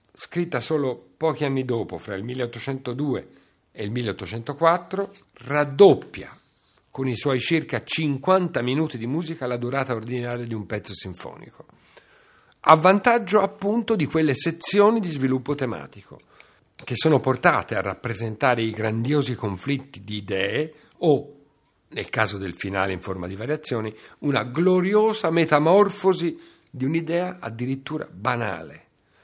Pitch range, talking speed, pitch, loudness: 115-165 Hz, 125 wpm, 135 Hz, -23 LUFS